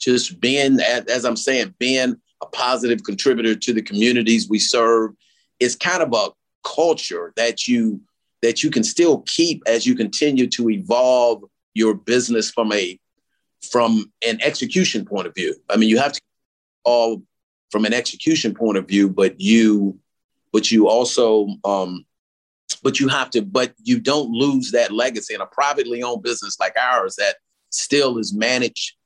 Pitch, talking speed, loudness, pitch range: 120 Hz, 165 wpm, -19 LUFS, 110-135 Hz